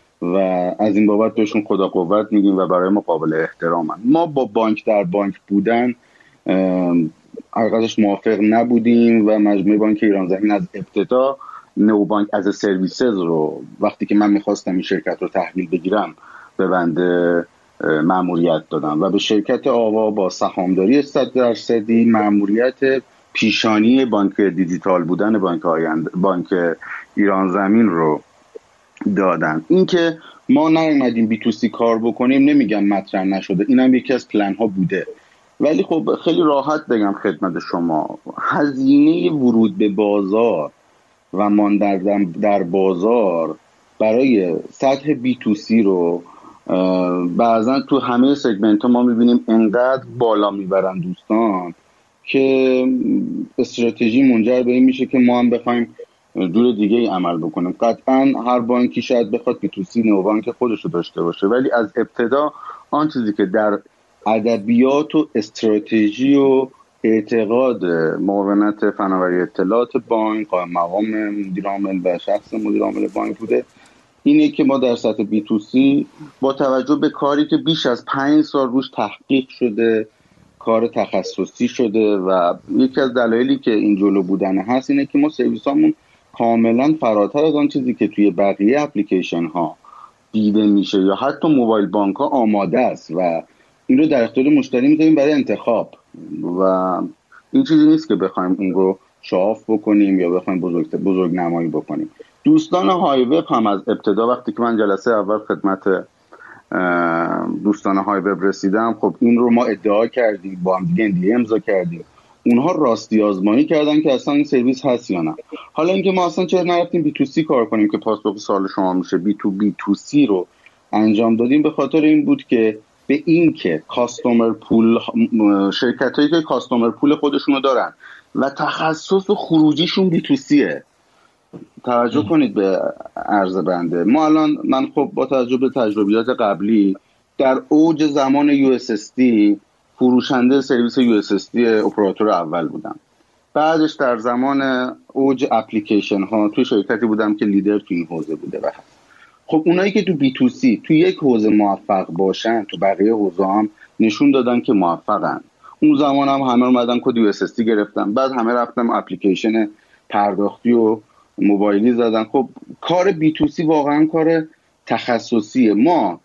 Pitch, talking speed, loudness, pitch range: 115 Hz, 150 wpm, -17 LUFS, 100-135 Hz